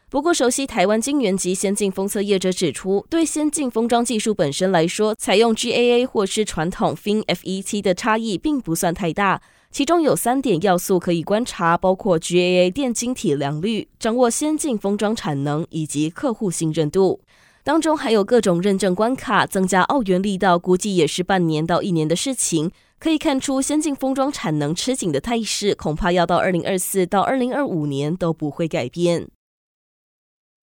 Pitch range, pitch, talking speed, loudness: 175-240 Hz, 195 Hz, 290 characters per minute, -20 LUFS